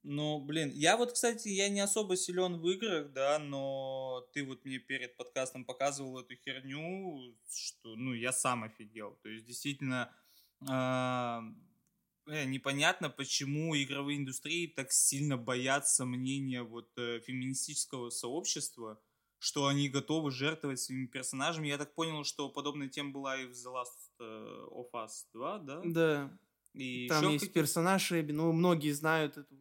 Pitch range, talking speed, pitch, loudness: 130-155 Hz, 140 wpm, 140 Hz, -35 LUFS